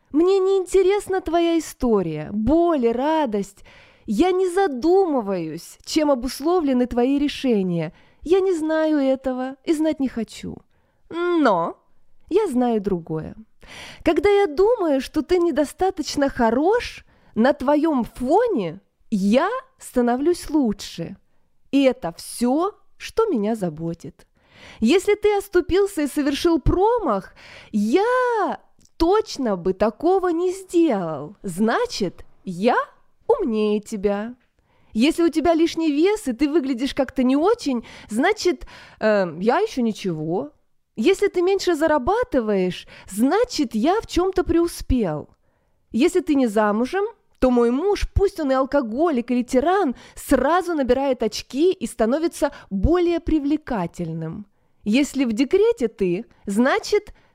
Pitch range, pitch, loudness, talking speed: 225-355 Hz, 280 Hz, -21 LUFS, 115 wpm